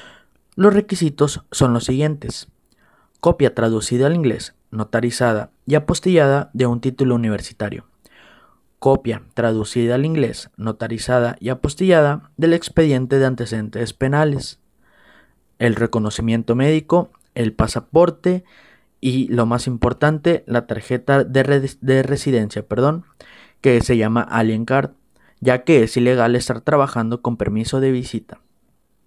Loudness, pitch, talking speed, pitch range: -18 LUFS, 125 Hz, 120 wpm, 115-145 Hz